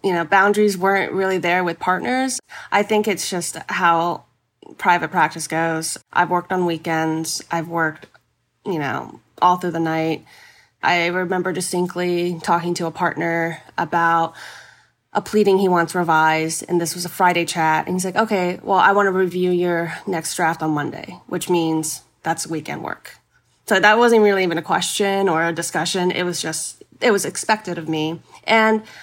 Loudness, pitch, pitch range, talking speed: -19 LUFS, 175 Hz, 165-185 Hz, 175 wpm